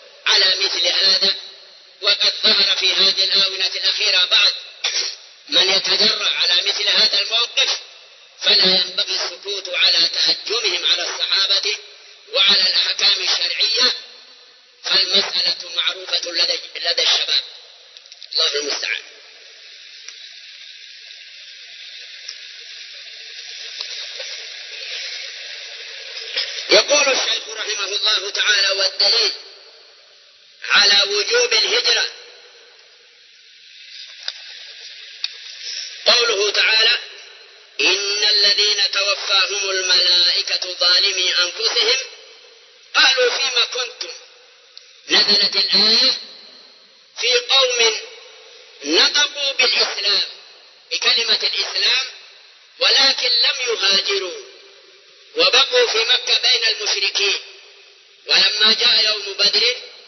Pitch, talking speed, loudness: 290 Hz, 75 wpm, -15 LUFS